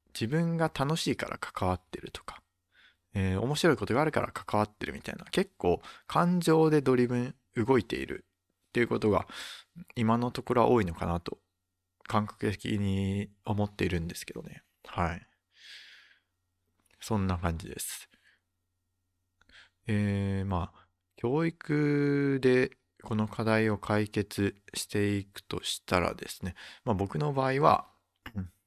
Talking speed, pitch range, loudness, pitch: 255 characters per minute, 95-130 Hz, -30 LUFS, 105 Hz